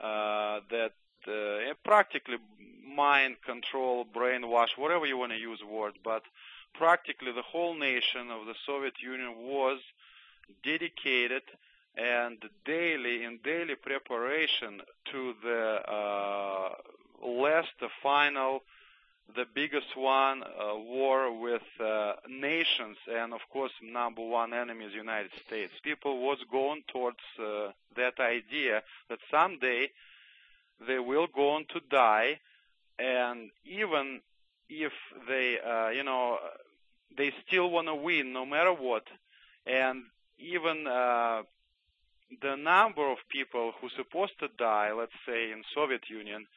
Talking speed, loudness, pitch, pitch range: 125 wpm, -31 LUFS, 125 Hz, 115-140 Hz